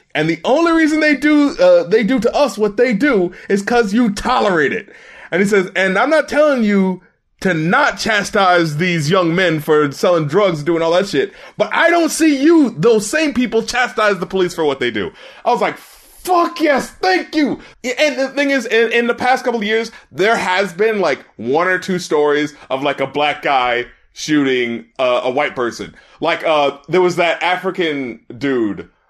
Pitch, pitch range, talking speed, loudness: 200 Hz, 170-255 Hz, 205 wpm, -15 LUFS